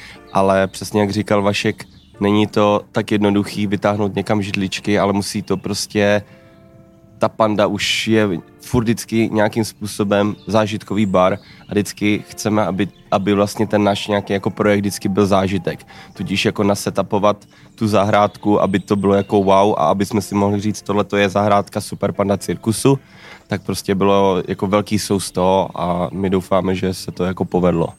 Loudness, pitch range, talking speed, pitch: -18 LUFS, 95-105 Hz, 165 wpm, 100 Hz